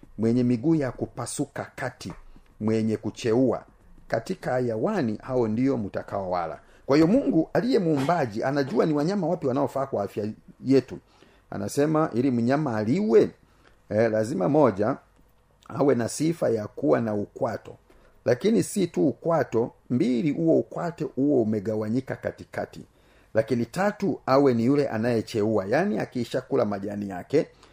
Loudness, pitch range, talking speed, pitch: -25 LUFS, 110-145 Hz, 130 wpm, 125 Hz